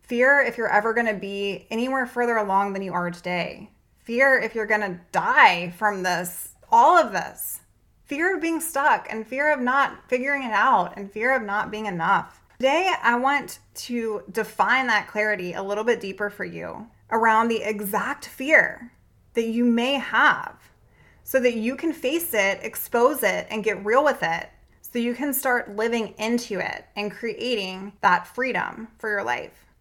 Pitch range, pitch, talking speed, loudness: 205-255 Hz, 225 Hz, 175 wpm, -23 LUFS